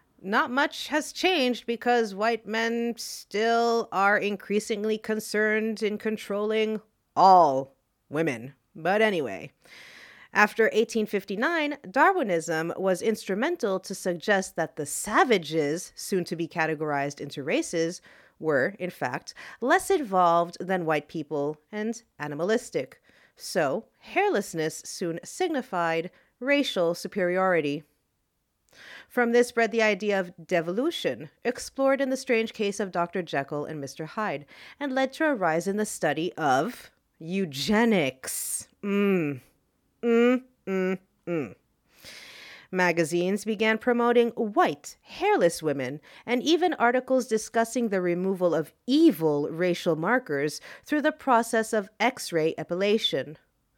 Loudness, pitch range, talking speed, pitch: -26 LUFS, 170-235 Hz, 115 wpm, 205 Hz